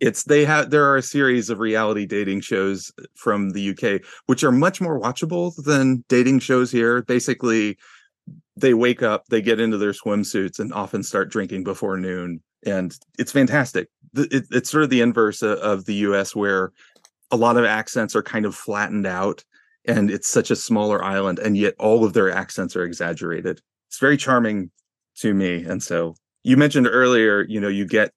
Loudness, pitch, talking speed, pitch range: -20 LUFS, 110 Hz, 185 wpm, 100-130 Hz